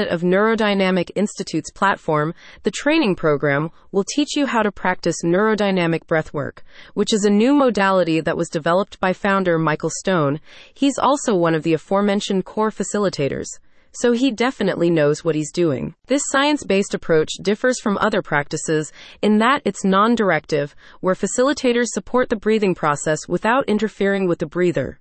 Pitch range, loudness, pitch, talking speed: 165-220 Hz, -19 LUFS, 195 Hz, 160 wpm